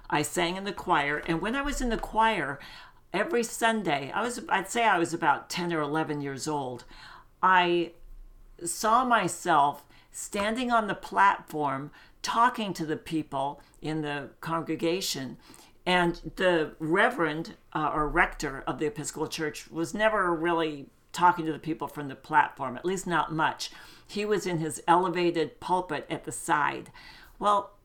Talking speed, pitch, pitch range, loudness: 160 wpm, 165 Hz, 150-185 Hz, -28 LUFS